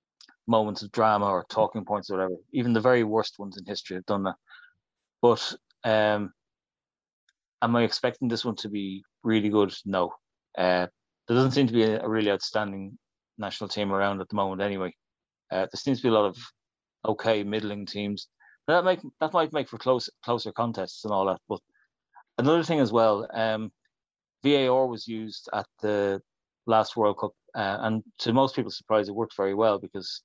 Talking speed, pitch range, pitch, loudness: 190 wpm, 100-115 Hz, 110 Hz, -27 LUFS